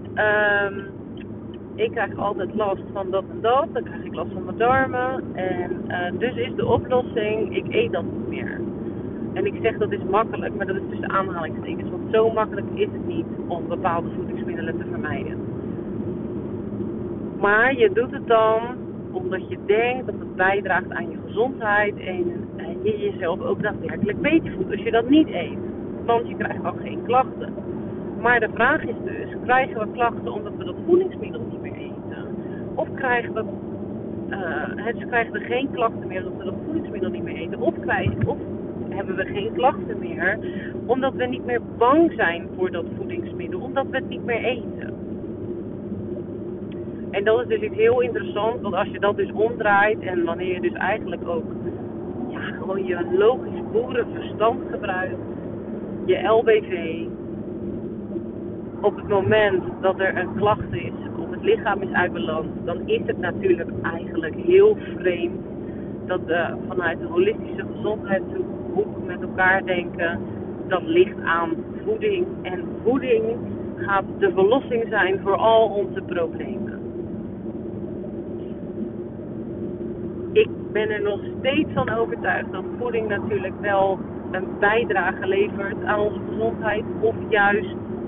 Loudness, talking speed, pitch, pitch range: -23 LUFS, 155 wpm, 210 Hz, 190-265 Hz